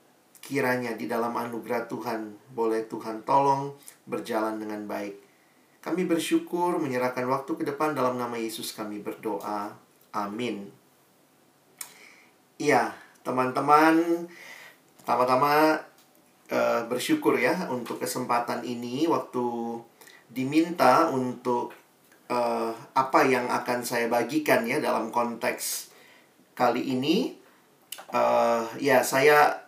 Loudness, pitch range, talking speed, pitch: -26 LUFS, 115-150 Hz, 100 wpm, 125 Hz